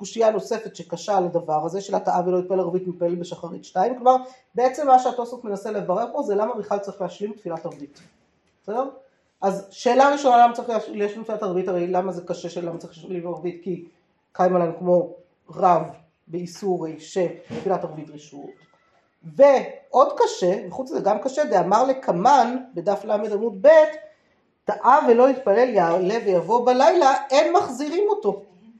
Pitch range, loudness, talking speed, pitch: 175-245 Hz, -21 LUFS, 160 wpm, 195 Hz